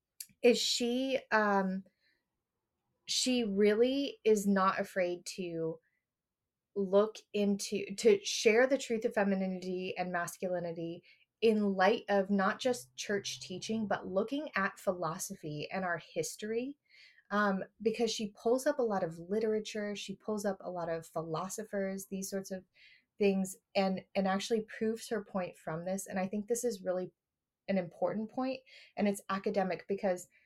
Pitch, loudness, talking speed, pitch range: 200 Hz, -34 LUFS, 145 wpm, 185-220 Hz